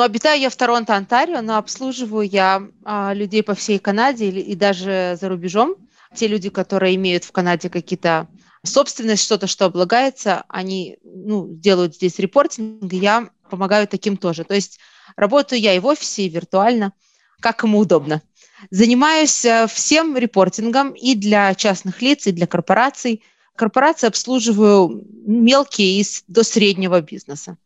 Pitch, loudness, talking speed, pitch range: 205 Hz, -17 LUFS, 145 wpm, 190-235 Hz